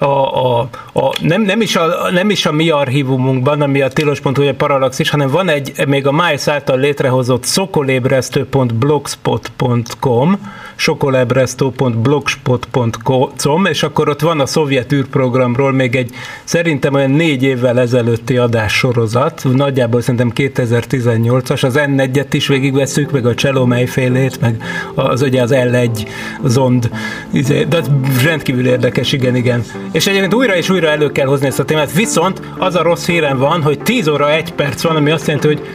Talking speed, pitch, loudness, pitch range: 155 wpm, 140 Hz, -13 LUFS, 125-150 Hz